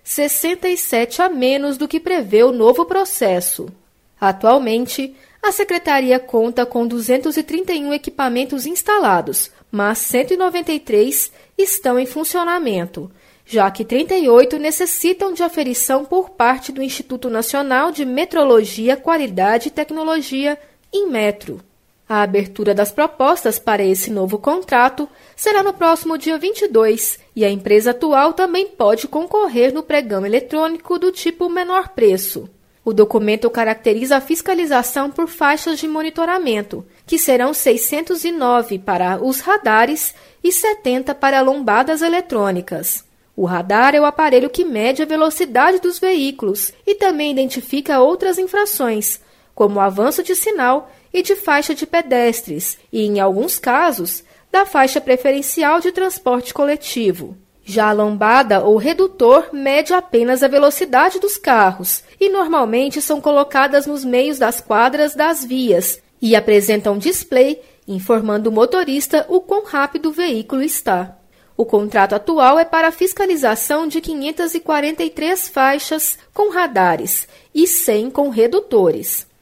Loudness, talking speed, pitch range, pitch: -16 LUFS, 130 wpm, 230-335 Hz, 280 Hz